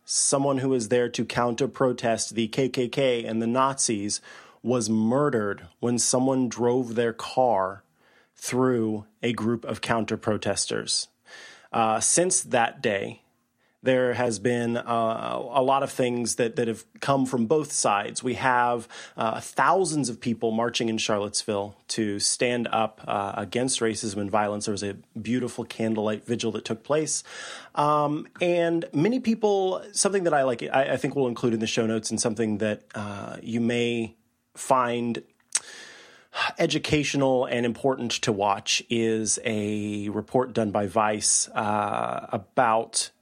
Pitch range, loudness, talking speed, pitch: 110-130 Hz, -25 LUFS, 150 wpm, 120 Hz